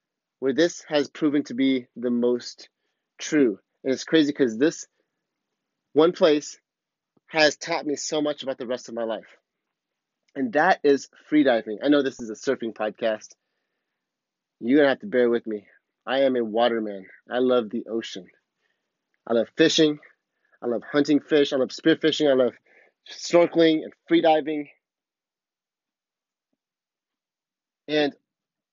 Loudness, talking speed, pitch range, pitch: -23 LUFS, 145 wpm, 120-150 Hz, 135 Hz